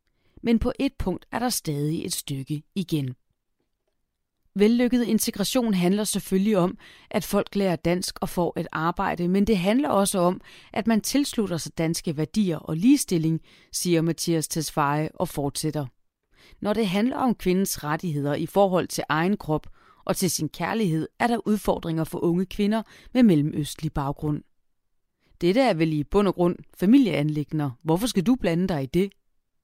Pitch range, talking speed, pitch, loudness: 155-210 Hz, 160 wpm, 180 Hz, -24 LUFS